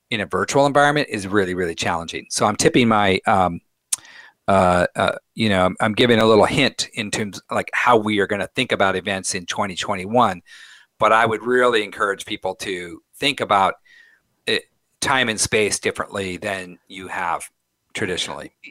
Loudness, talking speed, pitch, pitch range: -20 LUFS, 175 wpm, 105 Hz, 95-125 Hz